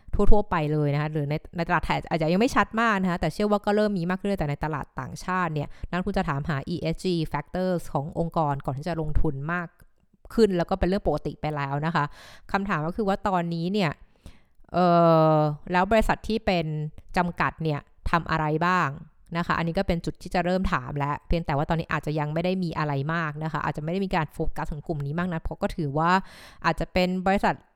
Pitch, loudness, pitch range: 170 Hz, -26 LUFS, 155-185 Hz